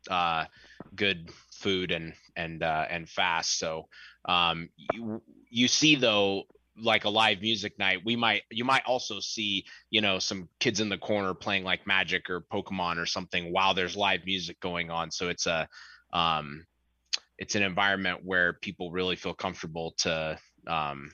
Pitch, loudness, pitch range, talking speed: 95 Hz, -28 LUFS, 85-105 Hz, 170 wpm